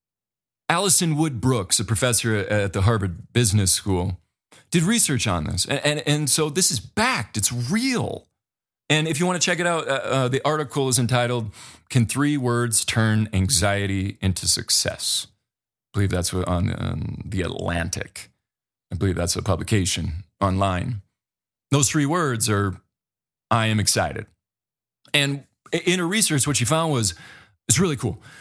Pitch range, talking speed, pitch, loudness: 100-145 Hz, 160 wpm, 120 Hz, -21 LUFS